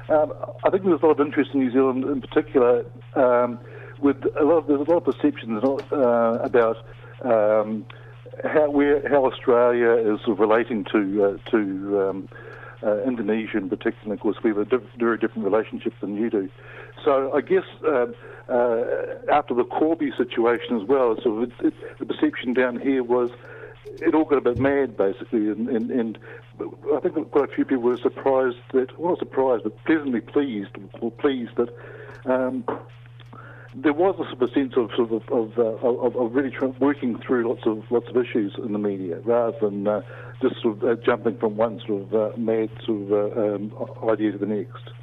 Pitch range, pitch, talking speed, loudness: 110-140 Hz, 120 Hz, 205 wpm, -23 LUFS